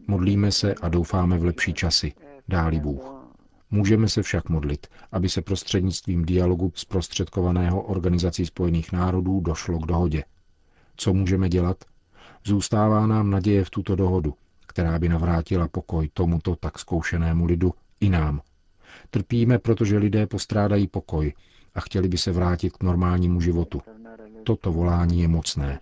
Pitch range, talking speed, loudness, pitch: 85-100 Hz, 140 wpm, -24 LUFS, 90 Hz